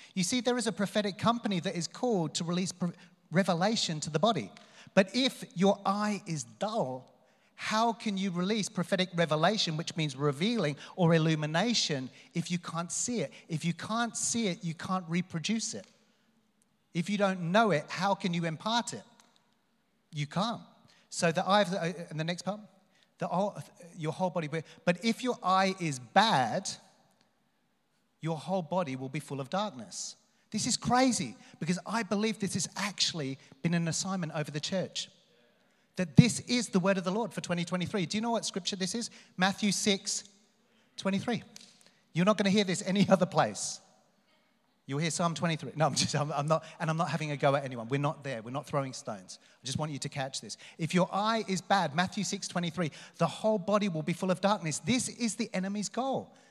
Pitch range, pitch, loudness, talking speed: 165-215 Hz, 190 Hz, -31 LUFS, 195 wpm